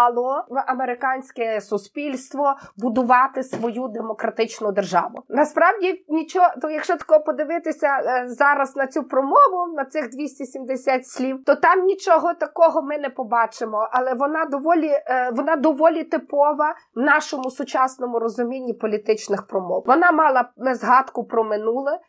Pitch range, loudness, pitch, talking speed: 245-310 Hz, -20 LUFS, 270 Hz, 125 wpm